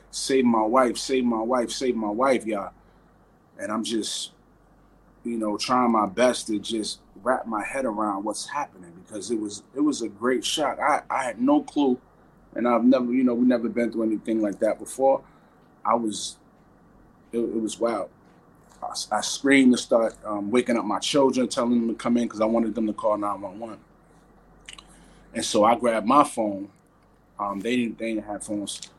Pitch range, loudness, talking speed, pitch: 105-125 Hz, -24 LUFS, 195 wpm, 115 Hz